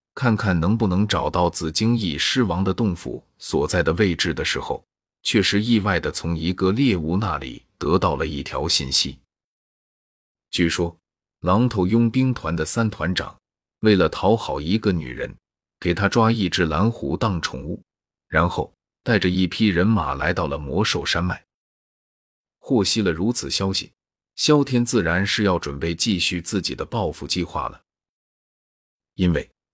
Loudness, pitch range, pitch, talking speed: -21 LUFS, 85-110 Hz, 95 Hz, 230 characters per minute